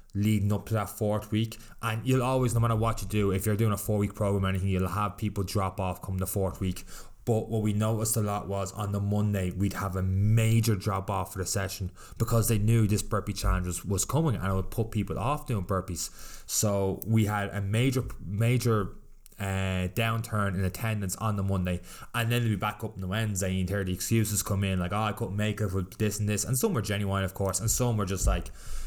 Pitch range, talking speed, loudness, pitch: 95-110 Hz, 245 wpm, -29 LUFS, 105 Hz